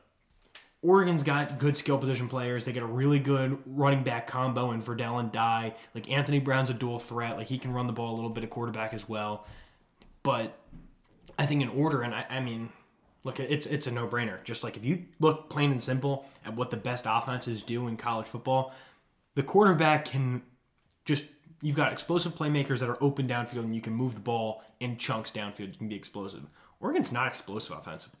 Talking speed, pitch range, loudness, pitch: 210 wpm, 115-140 Hz, -30 LUFS, 125 Hz